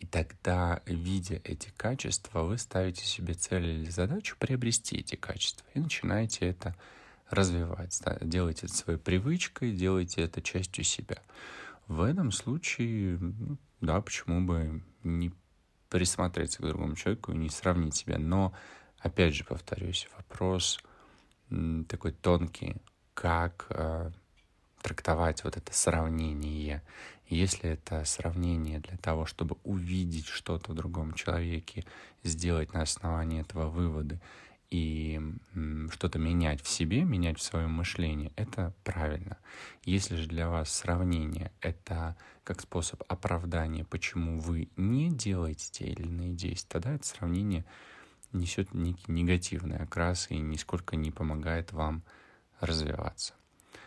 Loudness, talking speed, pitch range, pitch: -33 LUFS, 125 wpm, 80-95 Hz, 85 Hz